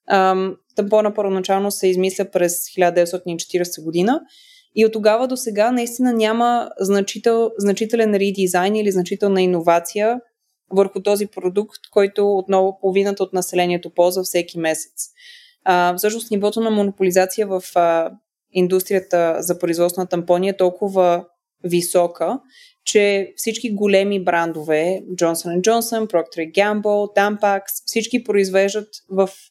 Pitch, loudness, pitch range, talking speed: 195 Hz, -19 LUFS, 180-215 Hz, 120 wpm